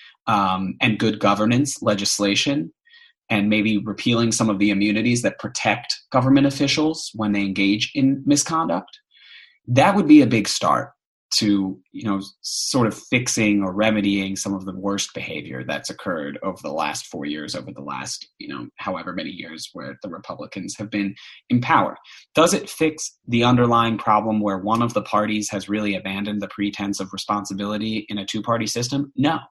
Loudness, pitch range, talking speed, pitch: -21 LUFS, 100-120 Hz, 175 wpm, 105 Hz